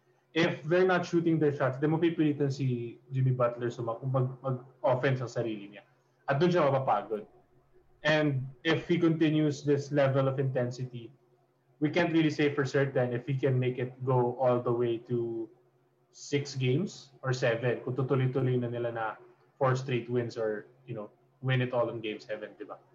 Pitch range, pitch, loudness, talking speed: 120-145 Hz, 130 Hz, -30 LUFS, 180 wpm